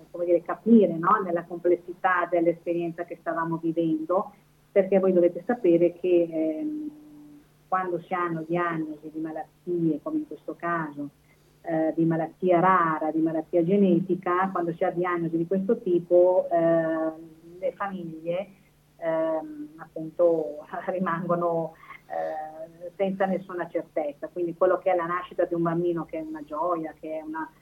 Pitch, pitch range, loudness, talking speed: 170 Hz, 160-180 Hz, -26 LUFS, 140 wpm